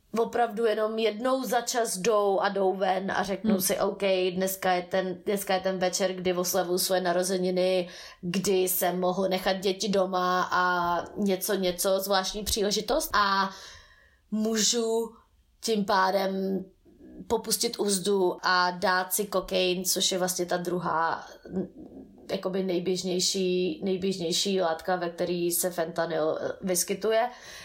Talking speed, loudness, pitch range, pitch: 130 wpm, -27 LUFS, 180-205 Hz, 190 Hz